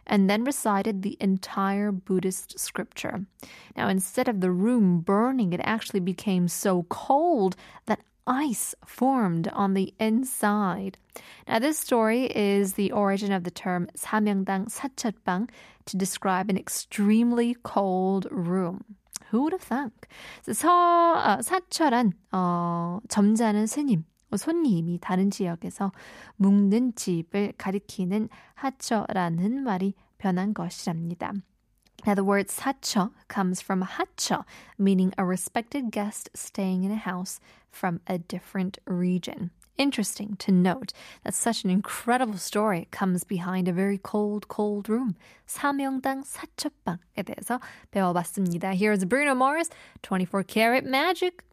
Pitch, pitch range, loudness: 205 Hz, 185-235 Hz, -26 LUFS